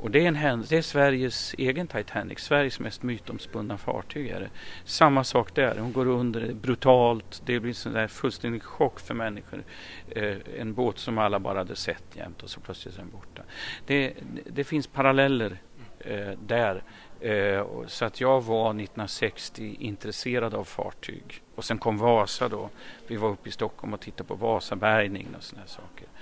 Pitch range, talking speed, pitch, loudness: 105-130 Hz, 185 wpm, 115 Hz, -27 LUFS